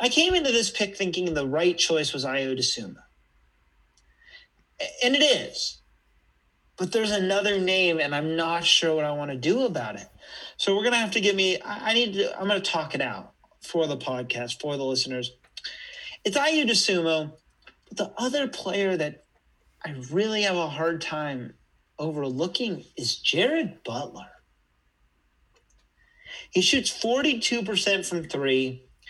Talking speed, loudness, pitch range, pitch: 150 wpm, -25 LUFS, 130-205 Hz, 165 Hz